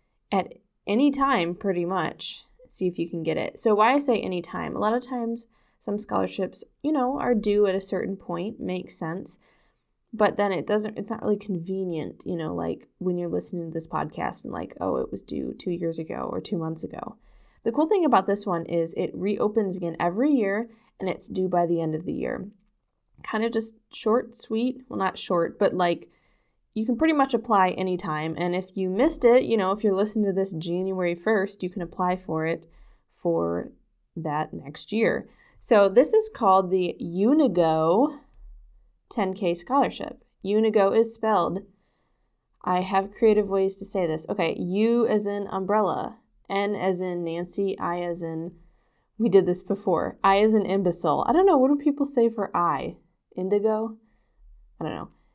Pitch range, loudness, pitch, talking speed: 175-225 Hz, -25 LUFS, 195 Hz, 190 wpm